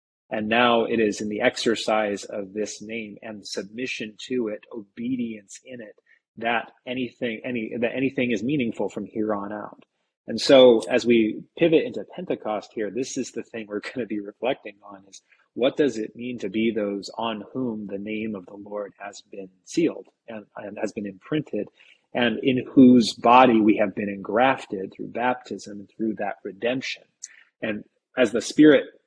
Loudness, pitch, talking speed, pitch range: -23 LUFS, 110 Hz, 180 wpm, 105-120 Hz